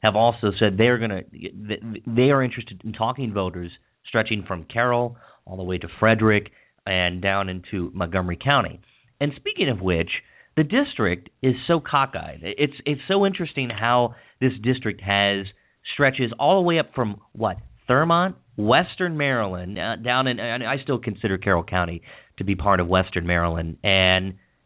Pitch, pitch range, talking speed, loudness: 110 Hz, 95-130 Hz, 165 wpm, -22 LUFS